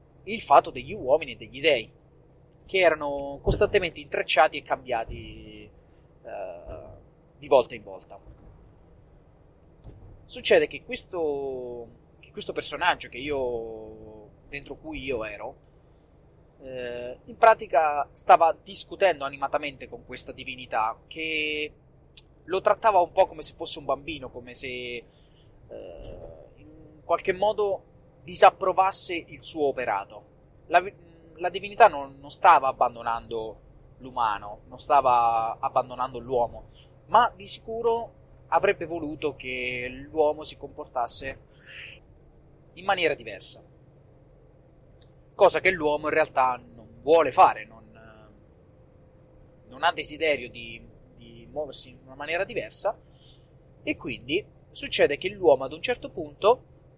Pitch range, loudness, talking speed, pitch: 120-165 Hz, -25 LUFS, 115 wpm, 140 Hz